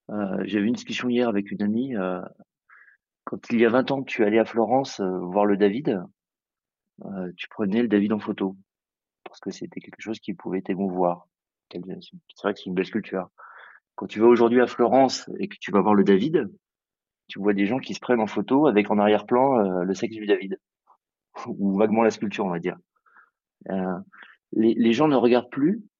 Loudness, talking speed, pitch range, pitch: -23 LUFS, 210 wpm, 100-120 Hz, 105 Hz